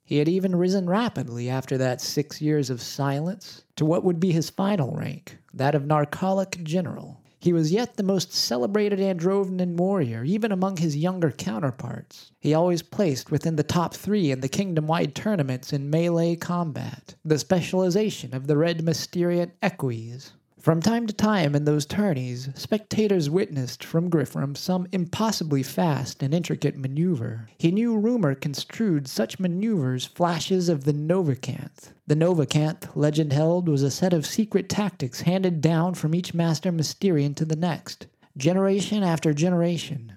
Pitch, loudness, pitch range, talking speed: 165 Hz, -24 LUFS, 145-185 Hz, 155 wpm